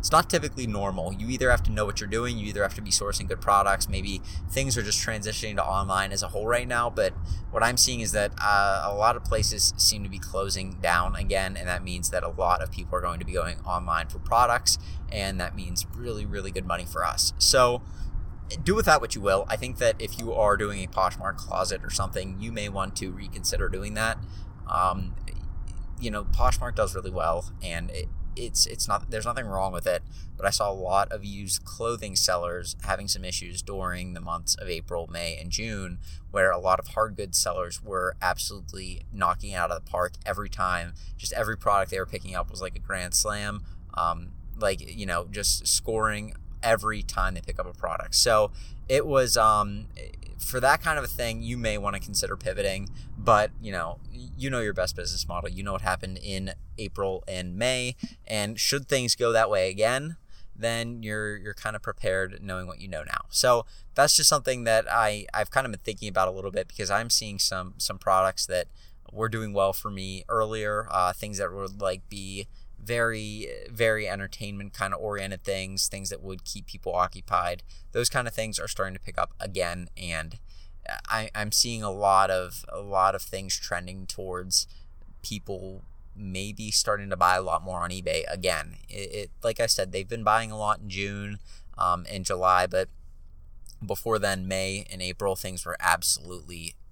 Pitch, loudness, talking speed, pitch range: 95 Hz, -27 LUFS, 210 wpm, 90-105 Hz